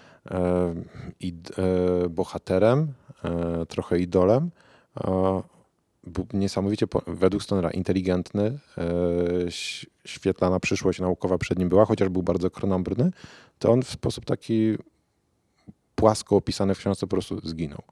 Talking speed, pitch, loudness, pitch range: 100 wpm, 95 Hz, -25 LUFS, 90-110 Hz